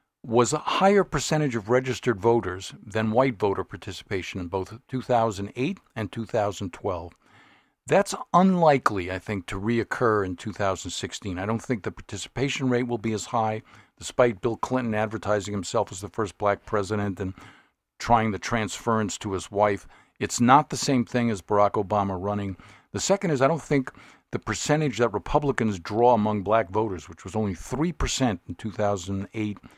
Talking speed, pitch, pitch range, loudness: 160 wpm, 110 Hz, 100-125 Hz, -25 LUFS